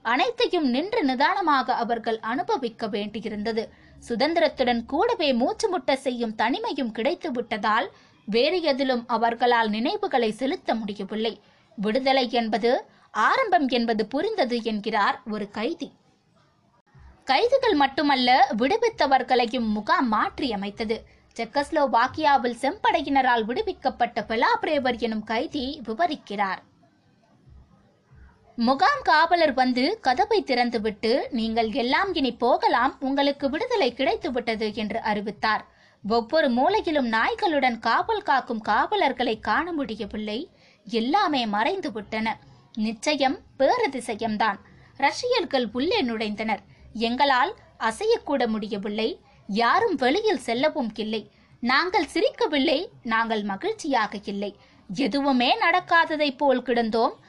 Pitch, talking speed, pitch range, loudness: 255 Hz, 90 wpm, 225-300 Hz, -24 LUFS